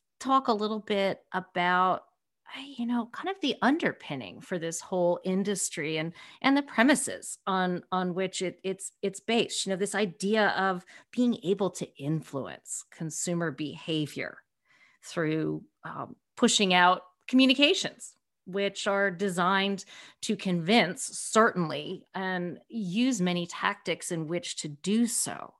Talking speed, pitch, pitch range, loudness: 135 wpm, 190 Hz, 175-220 Hz, -28 LUFS